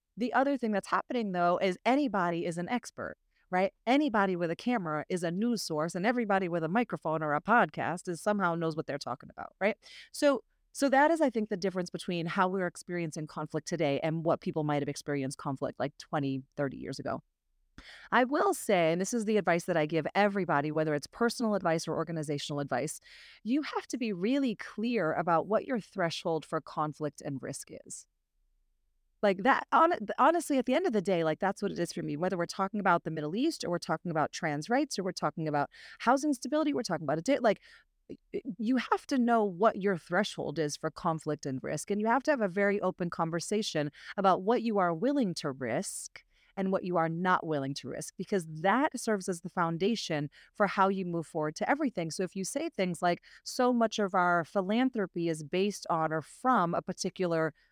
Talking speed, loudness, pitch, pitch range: 210 wpm, -31 LUFS, 180 Hz, 160-220 Hz